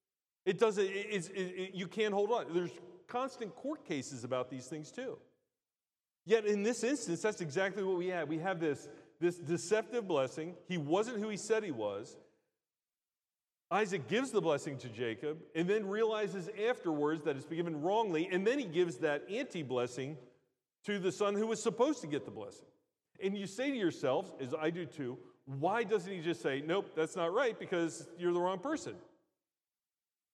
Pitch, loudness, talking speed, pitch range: 185 Hz, -36 LUFS, 185 wpm, 160-215 Hz